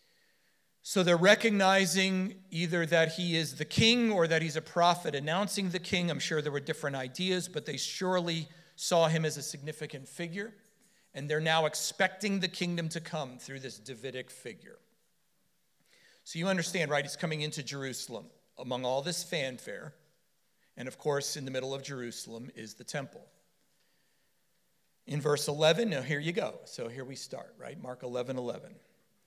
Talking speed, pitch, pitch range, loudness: 170 wpm, 160 Hz, 140-180 Hz, -31 LUFS